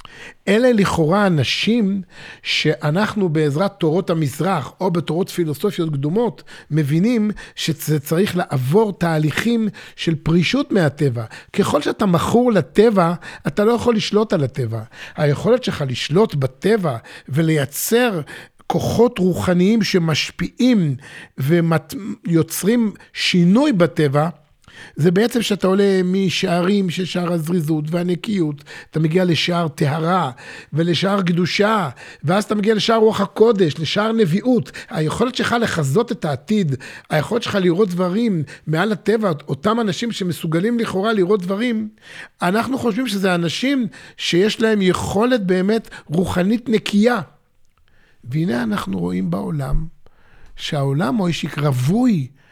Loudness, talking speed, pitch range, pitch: -18 LUFS, 115 wpm, 155-215 Hz, 180 Hz